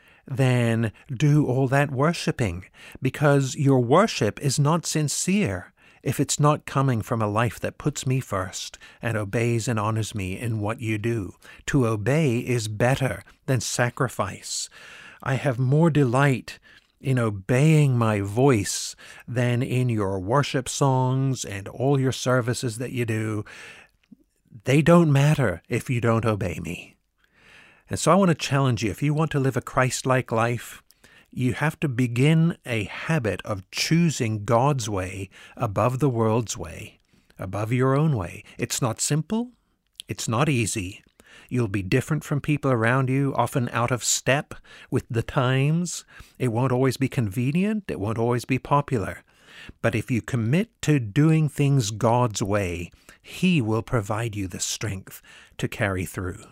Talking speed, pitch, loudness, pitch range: 155 wpm, 125 Hz, -24 LUFS, 110-140 Hz